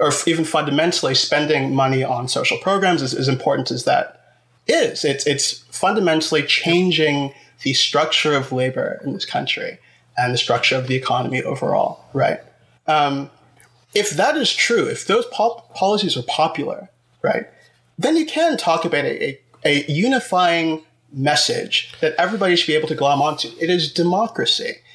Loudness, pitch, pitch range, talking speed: -19 LUFS, 155 Hz, 140-180 Hz, 160 wpm